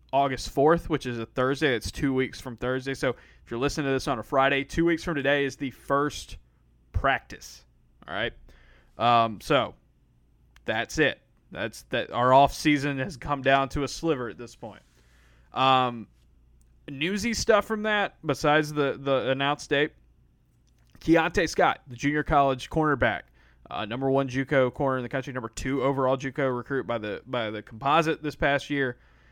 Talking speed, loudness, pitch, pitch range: 175 wpm, -26 LUFS, 135 Hz, 115-145 Hz